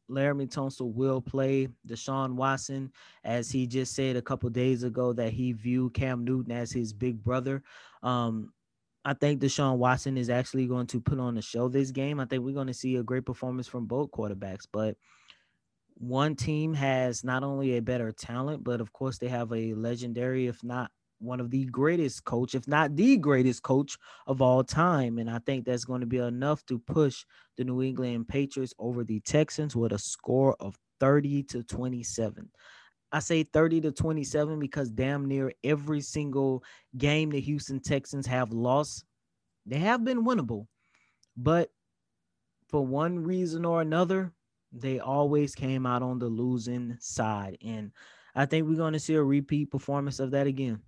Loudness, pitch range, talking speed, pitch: -30 LUFS, 120-140 Hz, 180 wpm, 130 Hz